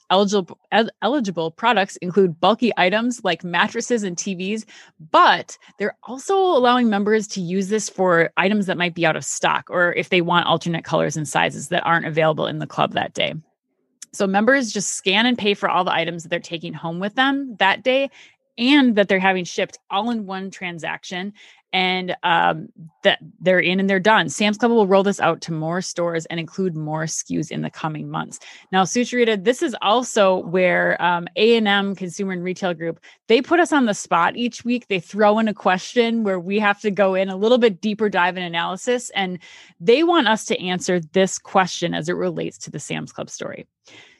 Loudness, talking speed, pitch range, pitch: -20 LUFS, 205 wpm, 175-220 Hz, 195 Hz